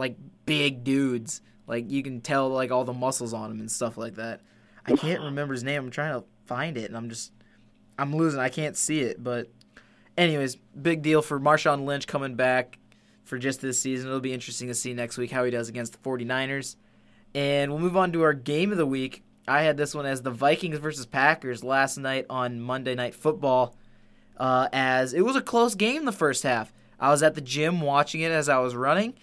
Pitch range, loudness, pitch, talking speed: 125-150 Hz, -26 LUFS, 135 Hz, 220 wpm